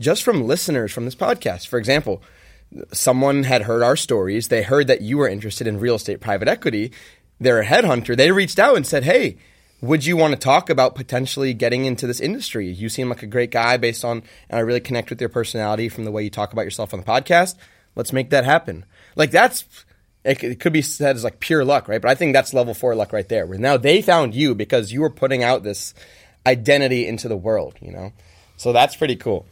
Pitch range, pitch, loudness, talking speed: 110-135 Hz, 120 Hz, -19 LUFS, 230 wpm